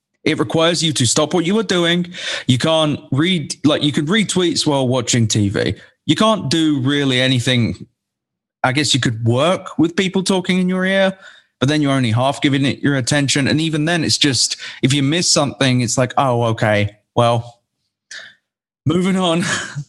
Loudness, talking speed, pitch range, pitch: -16 LUFS, 185 wpm, 125-170 Hz, 145 Hz